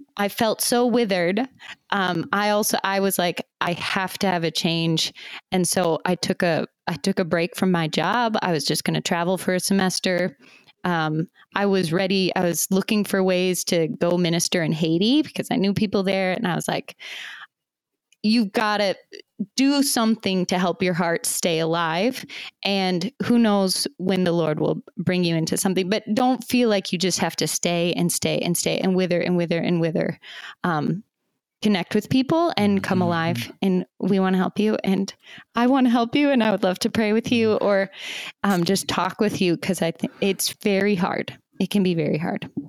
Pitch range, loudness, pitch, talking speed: 175-215 Hz, -22 LUFS, 190 Hz, 205 wpm